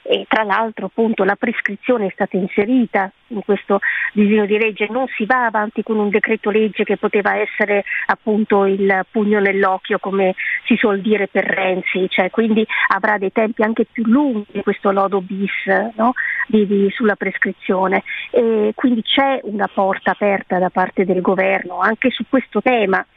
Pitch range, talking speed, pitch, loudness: 195-225 Hz, 160 wpm, 210 Hz, -17 LUFS